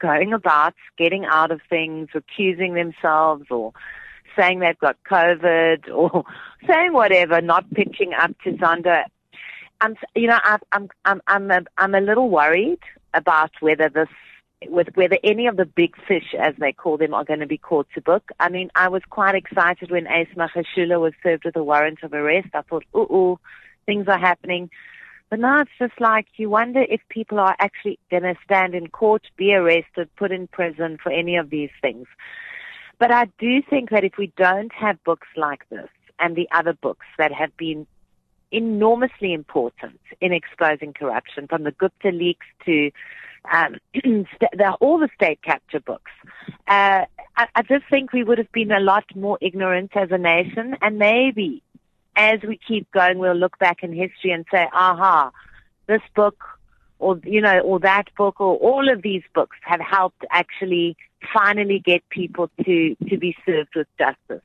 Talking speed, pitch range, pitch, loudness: 180 wpm, 170-215 Hz, 185 Hz, -19 LUFS